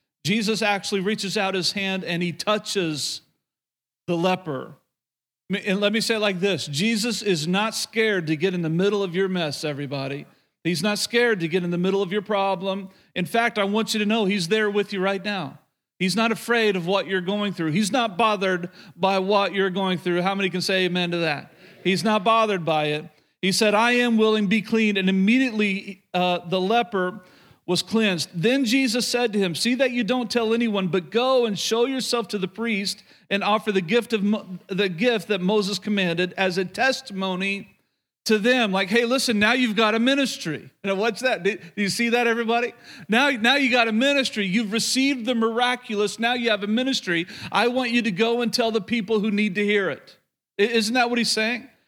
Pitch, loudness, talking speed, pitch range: 205 Hz, -22 LUFS, 210 wpm, 190-230 Hz